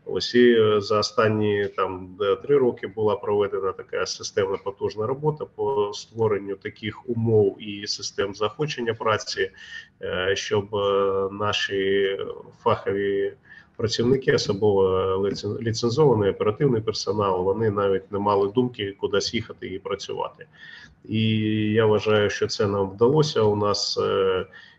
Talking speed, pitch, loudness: 115 wpm, 110 Hz, -23 LUFS